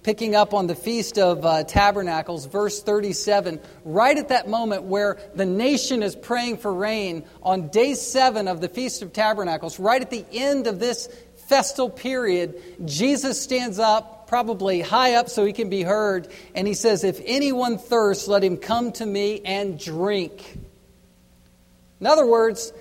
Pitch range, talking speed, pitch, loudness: 185-235 Hz, 170 wpm, 205 Hz, -22 LUFS